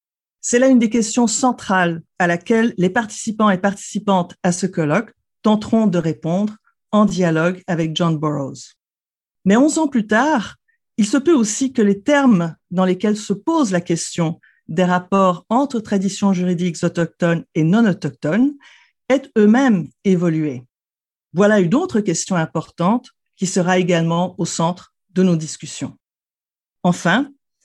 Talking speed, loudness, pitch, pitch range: 145 wpm, -18 LUFS, 195 Hz, 175-230 Hz